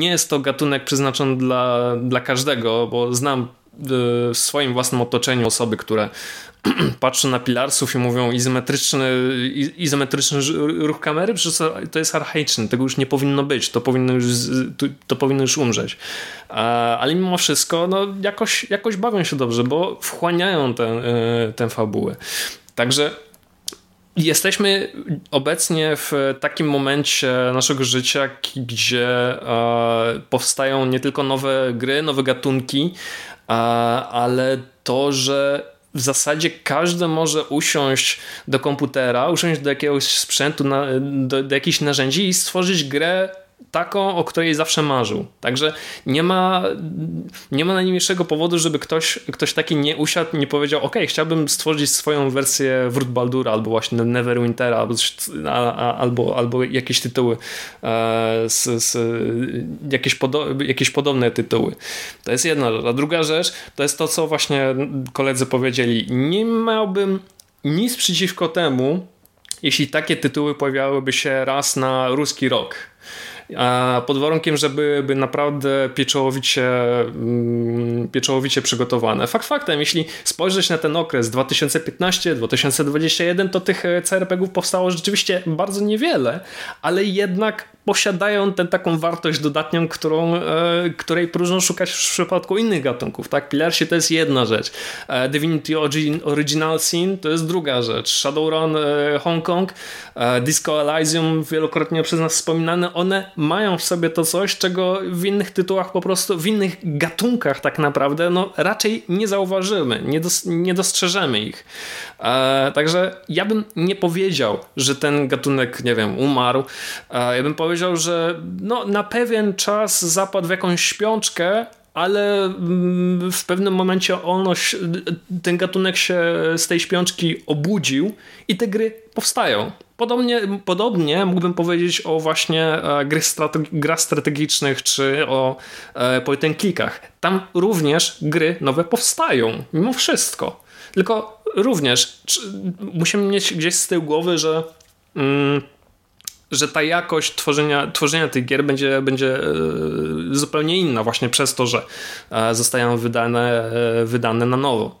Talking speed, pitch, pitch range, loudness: 135 wpm, 150 Hz, 130-175 Hz, -19 LUFS